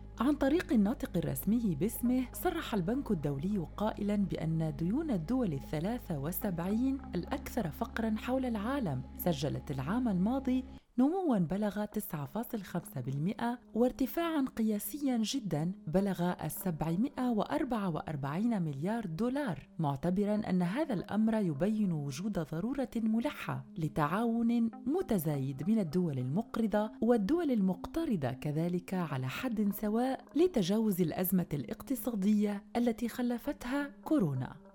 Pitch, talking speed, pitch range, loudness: 210 Hz, 95 wpm, 175-245 Hz, -33 LUFS